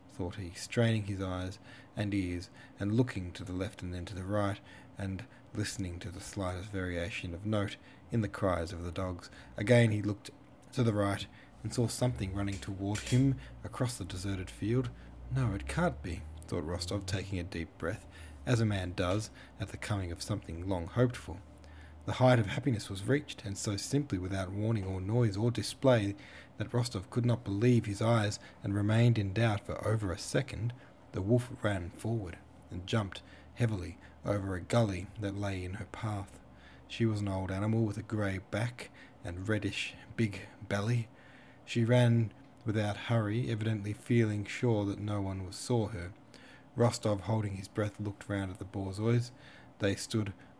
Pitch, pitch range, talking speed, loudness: 105 Hz, 95-115 Hz, 180 wpm, -34 LUFS